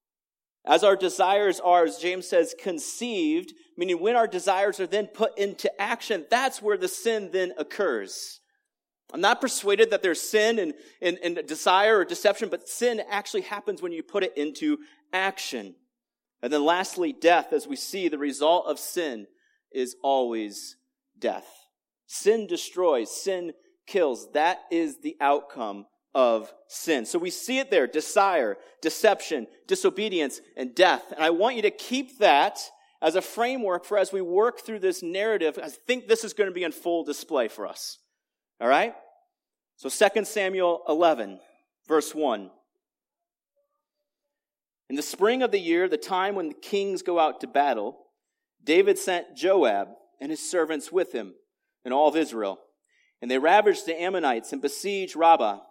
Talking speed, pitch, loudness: 165 wpm, 220 Hz, -25 LUFS